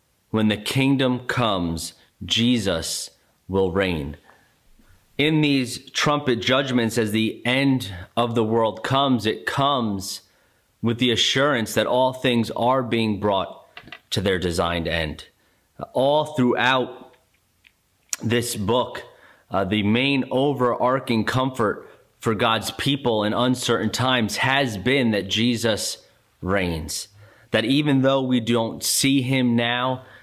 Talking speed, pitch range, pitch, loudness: 120 wpm, 105-130 Hz, 120 Hz, -22 LUFS